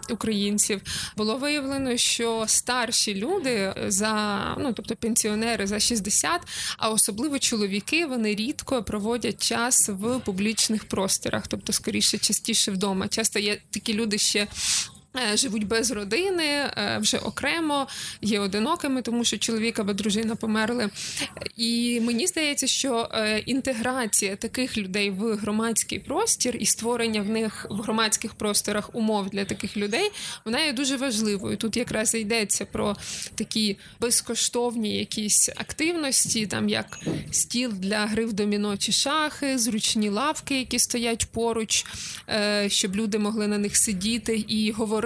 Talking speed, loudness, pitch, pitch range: 130 wpm, -24 LUFS, 225 Hz, 210-245 Hz